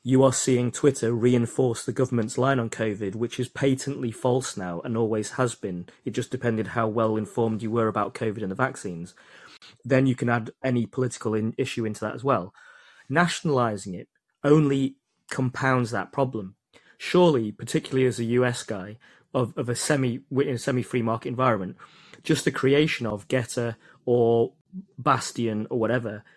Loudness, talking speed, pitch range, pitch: -25 LUFS, 170 wpm, 110-135 Hz, 120 Hz